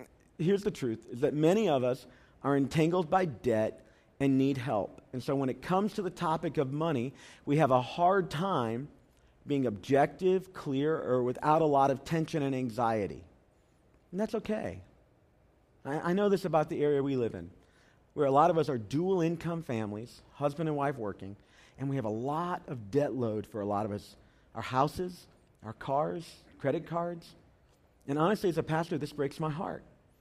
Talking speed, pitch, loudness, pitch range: 190 wpm, 140 Hz, -31 LUFS, 120-165 Hz